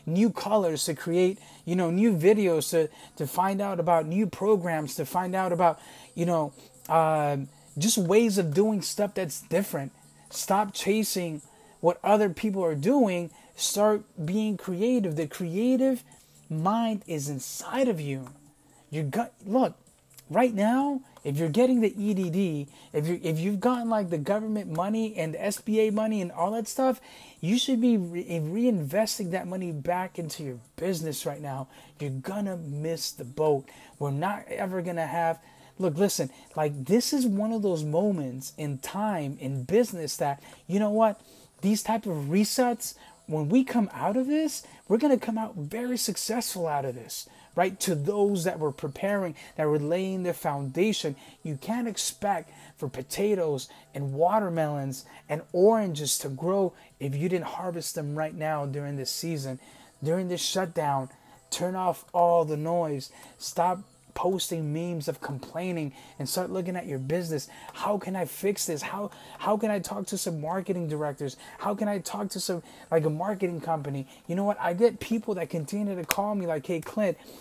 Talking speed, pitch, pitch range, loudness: 170 wpm, 175 Hz, 155-205 Hz, -28 LUFS